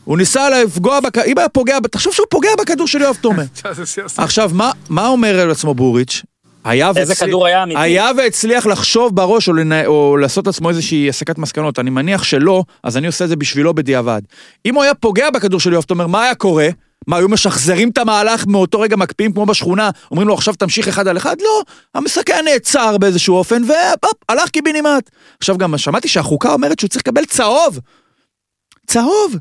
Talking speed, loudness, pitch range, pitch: 180 wpm, -13 LUFS, 170-250 Hz, 195 Hz